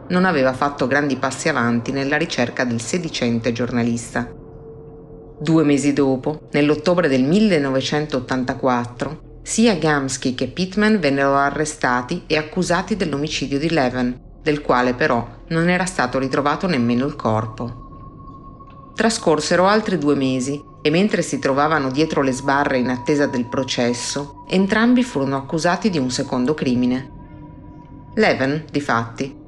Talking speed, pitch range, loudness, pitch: 130 wpm, 130-155 Hz, -19 LUFS, 140 Hz